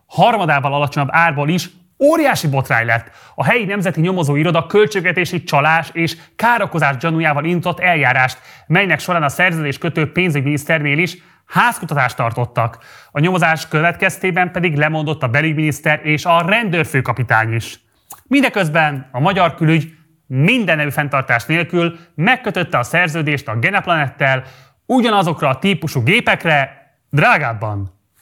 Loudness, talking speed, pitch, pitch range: -15 LUFS, 120 wpm, 160 Hz, 140-180 Hz